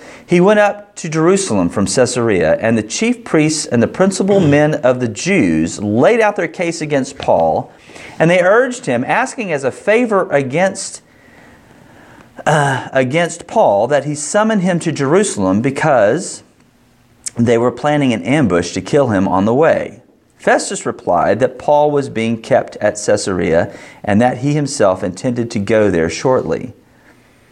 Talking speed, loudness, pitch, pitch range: 155 wpm, -14 LUFS, 145 Hz, 120-185 Hz